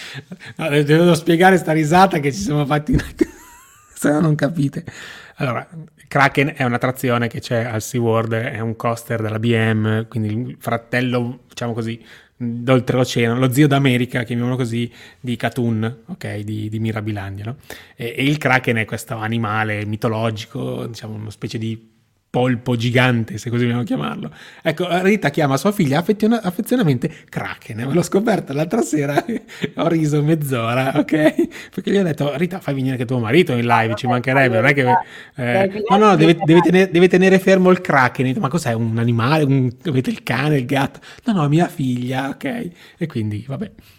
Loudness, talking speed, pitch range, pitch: -18 LUFS, 175 wpm, 115-160 Hz, 130 Hz